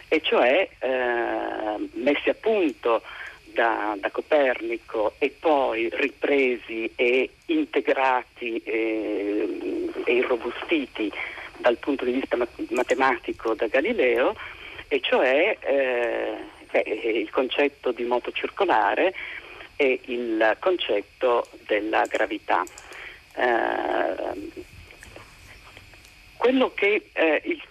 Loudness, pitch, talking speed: -24 LUFS, 320 Hz, 95 wpm